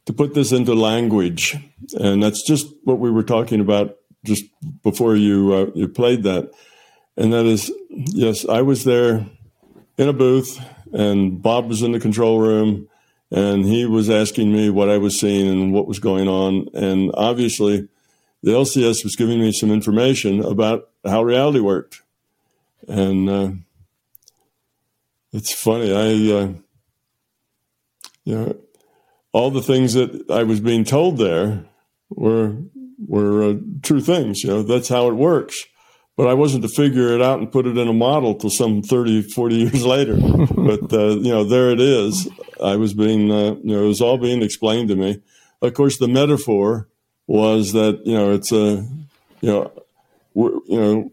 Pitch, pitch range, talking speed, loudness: 110 Hz, 105-125 Hz, 170 wpm, -18 LUFS